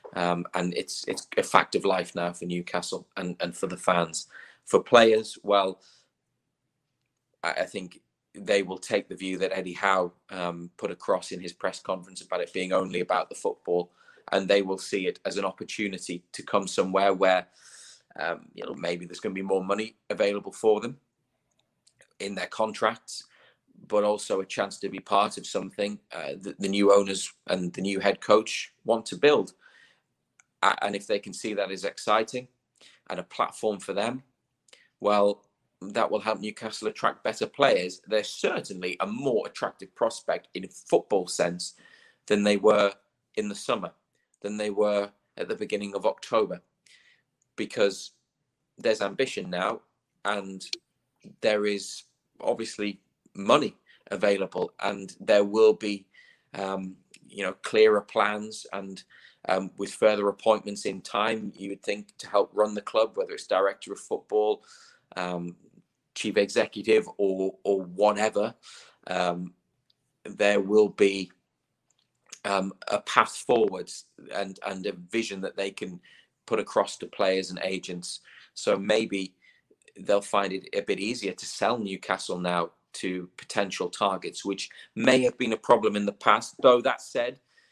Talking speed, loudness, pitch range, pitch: 160 wpm, -27 LUFS, 95-110 Hz, 100 Hz